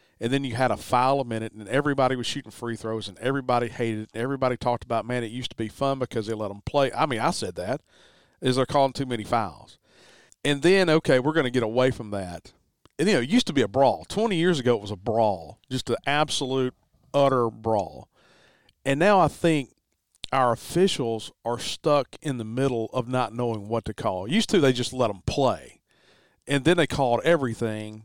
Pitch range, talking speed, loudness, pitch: 115-140 Hz, 220 wpm, -25 LUFS, 125 Hz